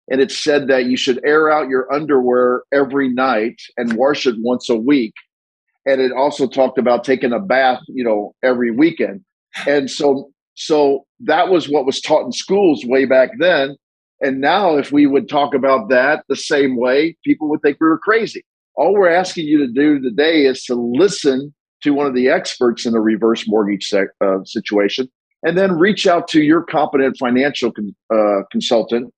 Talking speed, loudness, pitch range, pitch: 190 wpm, -16 LUFS, 125-145 Hz, 135 Hz